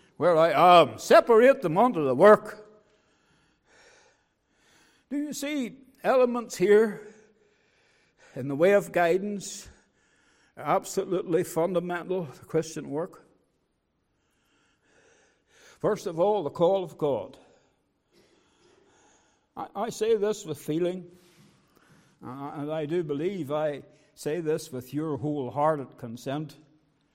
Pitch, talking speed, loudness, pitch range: 175 Hz, 110 wpm, -25 LUFS, 150-215 Hz